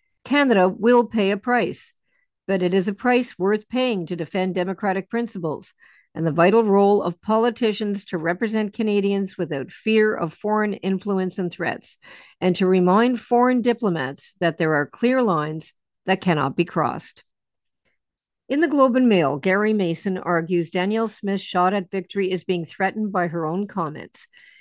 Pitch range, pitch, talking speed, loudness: 175-220 Hz, 195 Hz, 160 wpm, -21 LUFS